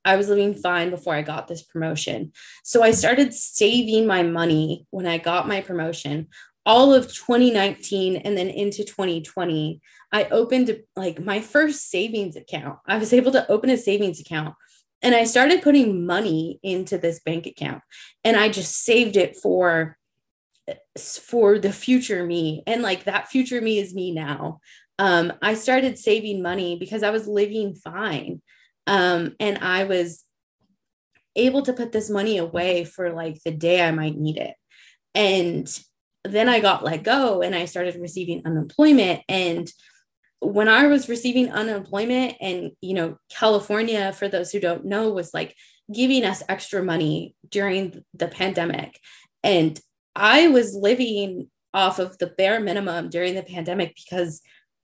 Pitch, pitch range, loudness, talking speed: 195 Hz, 175-220 Hz, -21 LUFS, 160 wpm